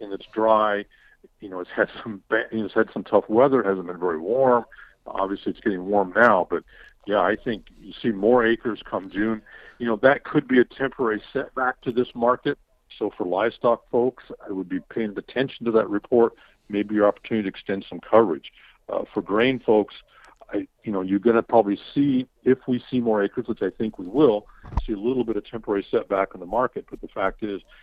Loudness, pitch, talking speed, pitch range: -23 LUFS, 115 Hz, 215 wpm, 100-125 Hz